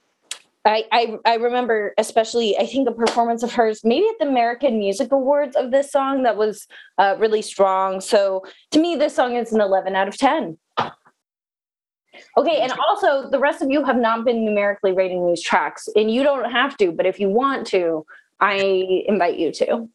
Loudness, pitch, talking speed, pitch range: -19 LUFS, 230 Hz, 195 wpm, 200-275 Hz